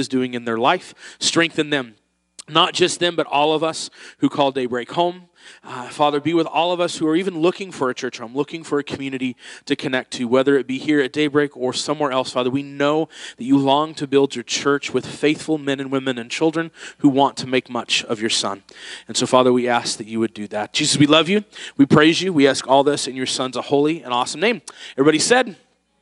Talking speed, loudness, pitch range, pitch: 240 wpm, -19 LUFS, 130-155 Hz, 140 Hz